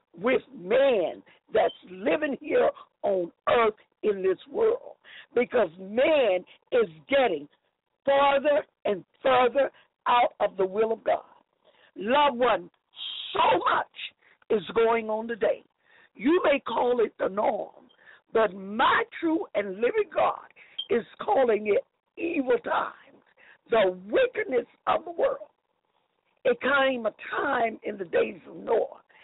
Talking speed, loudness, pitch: 125 wpm, -26 LUFS, 290 Hz